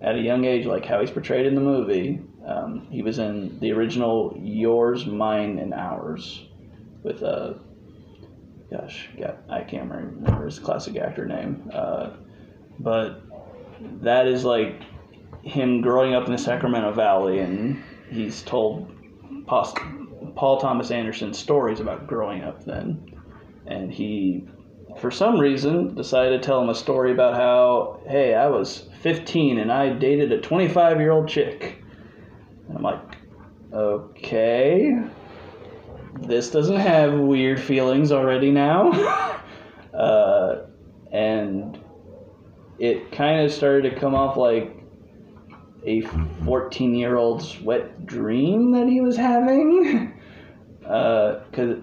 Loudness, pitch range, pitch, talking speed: -22 LUFS, 110-145 Hz, 130 Hz, 125 wpm